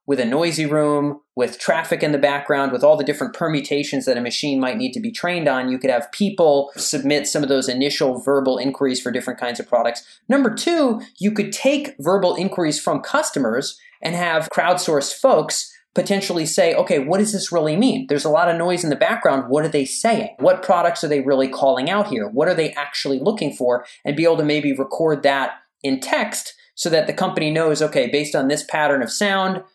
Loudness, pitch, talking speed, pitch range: -19 LUFS, 150 Hz, 215 wpm, 140-185 Hz